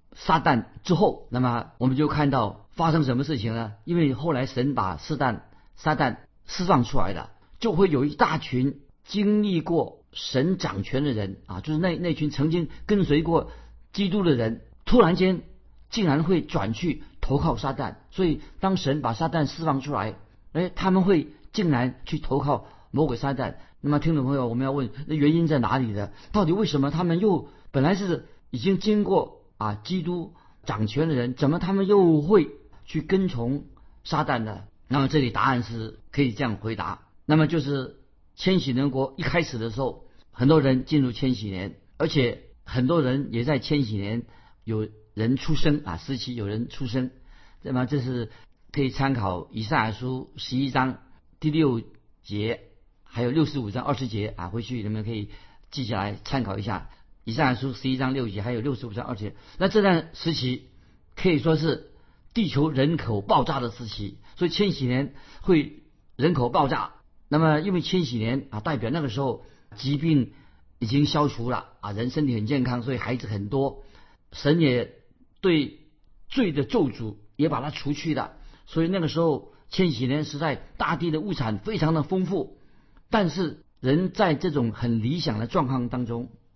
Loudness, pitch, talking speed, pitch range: -25 LUFS, 135 Hz, 260 characters per minute, 115-160 Hz